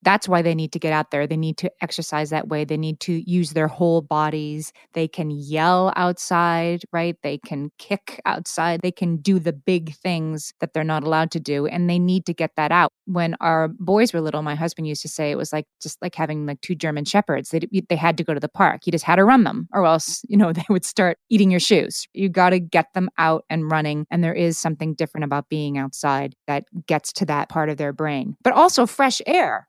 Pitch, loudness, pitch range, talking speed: 165 Hz, -21 LUFS, 155-180 Hz, 245 wpm